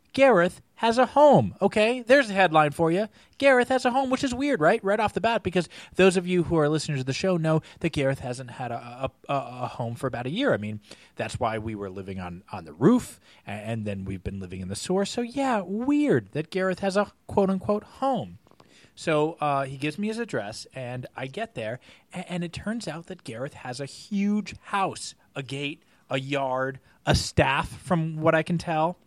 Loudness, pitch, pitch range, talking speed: -25 LUFS, 160 Hz, 130-205 Hz, 225 wpm